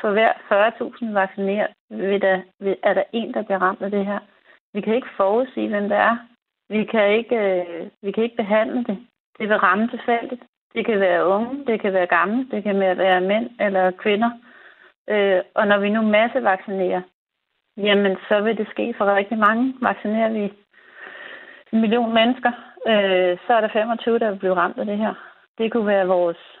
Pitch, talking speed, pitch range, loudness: 210 Hz, 180 wpm, 195-230 Hz, -20 LUFS